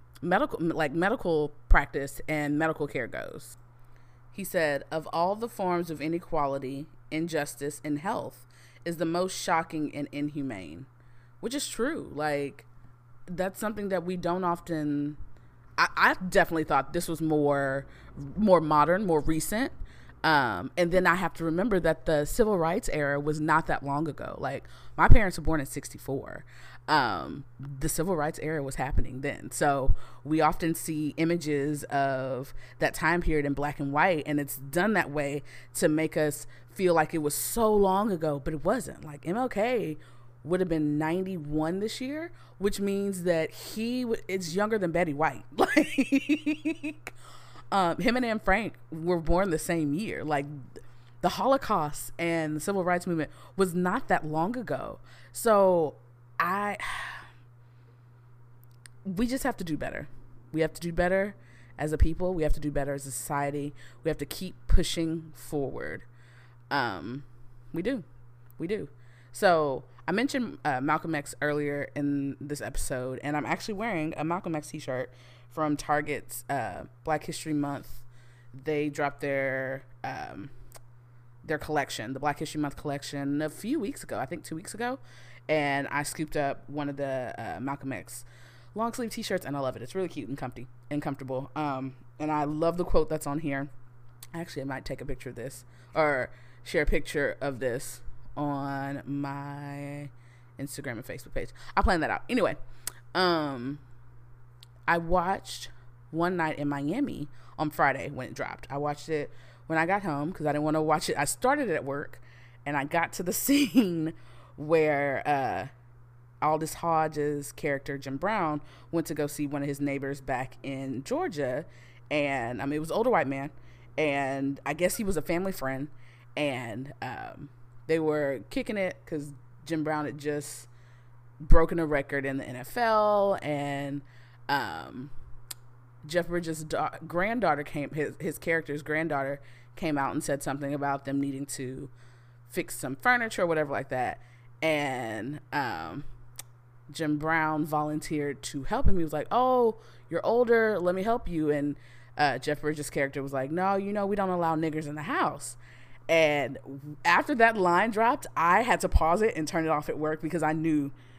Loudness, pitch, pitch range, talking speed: -29 LUFS, 145 Hz, 130-165 Hz, 170 wpm